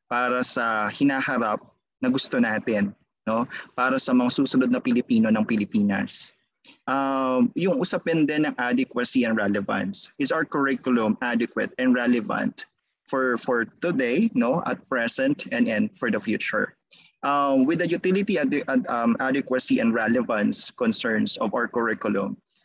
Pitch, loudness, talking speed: 140 Hz, -24 LUFS, 145 wpm